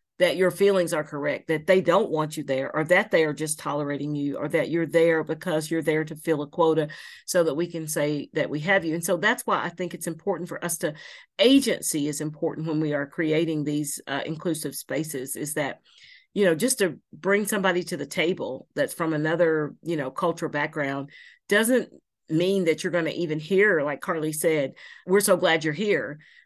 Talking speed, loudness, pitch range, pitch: 215 wpm, -25 LUFS, 150-180 Hz, 165 Hz